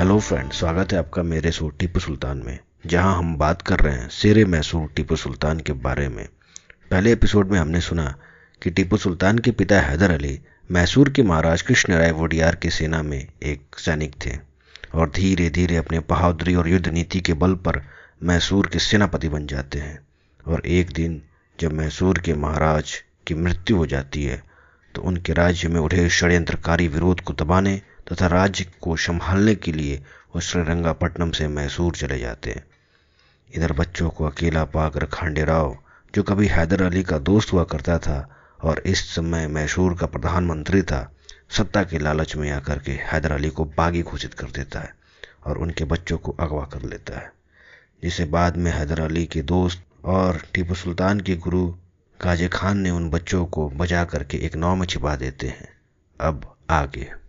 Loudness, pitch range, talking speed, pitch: -22 LUFS, 75-90 Hz, 180 wpm, 85 Hz